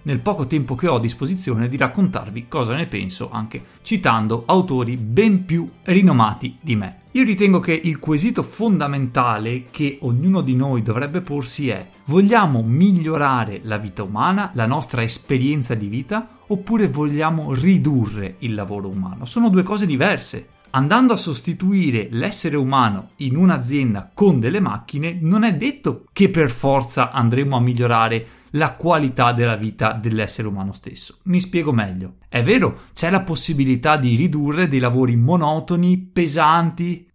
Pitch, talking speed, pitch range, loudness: 140 Hz, 150 wpm, 120-175 Hz, -19 LUFS